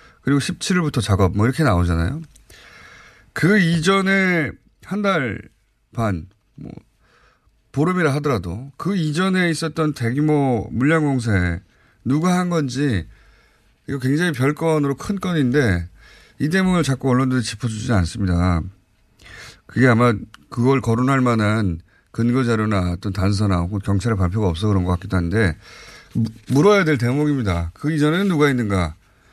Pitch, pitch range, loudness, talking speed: 125 Hz, 100-150 Hz, -19 LUFS, 285 characters per minute